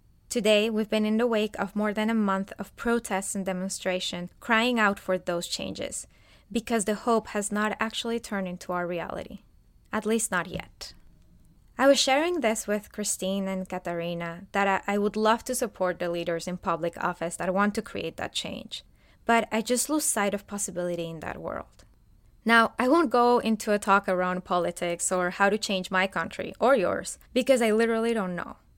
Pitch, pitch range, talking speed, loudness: 205 Hz, 185-225 Hz, 190 wpm, -27 LUFS